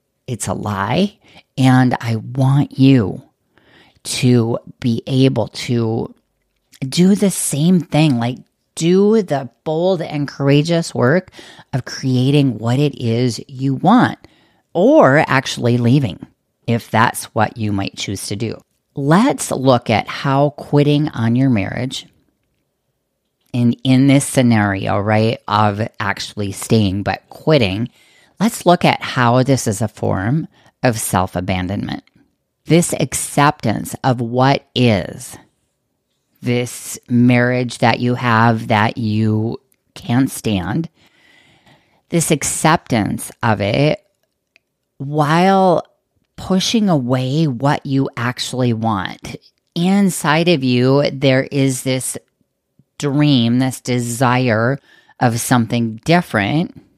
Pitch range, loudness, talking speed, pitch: 115-145 Hz, -16 LUFS, 110 wpm, 130 Hz